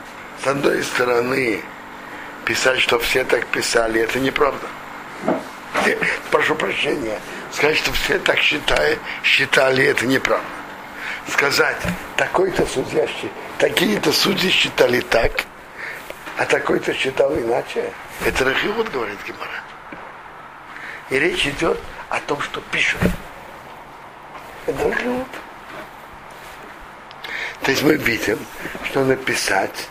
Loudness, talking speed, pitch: -19 LUFS, 100 wpm, 135 Hz